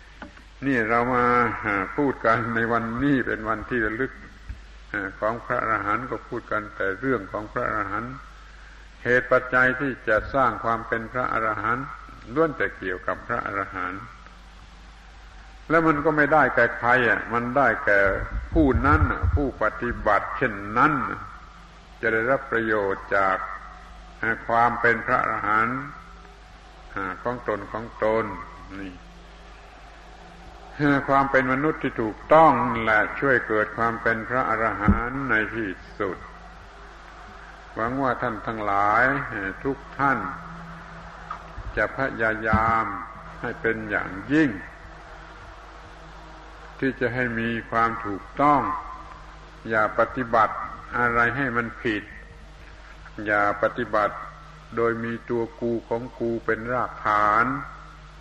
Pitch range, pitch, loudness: 110-125 Hz, 115 Hz, -23 LUFS